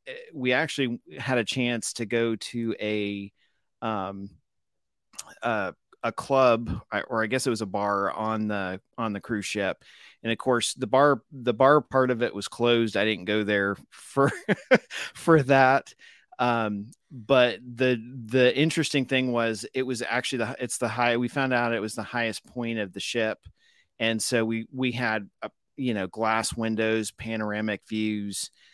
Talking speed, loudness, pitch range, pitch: 170 wpm, -26 LUFS, 110-125 Hz, 115 Hz